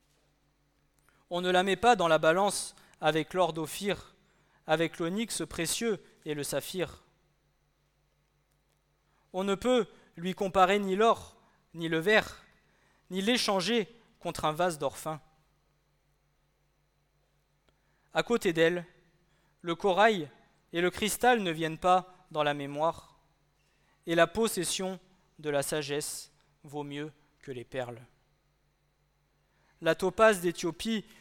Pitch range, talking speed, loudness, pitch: 155-195 Hz, 120 wpm, -29 LUFS, 175 Hz